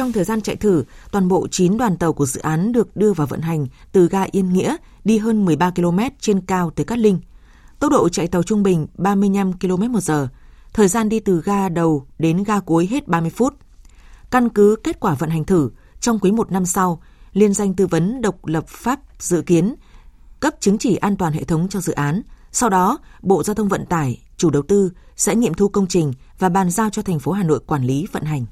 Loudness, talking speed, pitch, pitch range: -19 LUFS, 230 wpm, 190 Hz, 165-210 Hz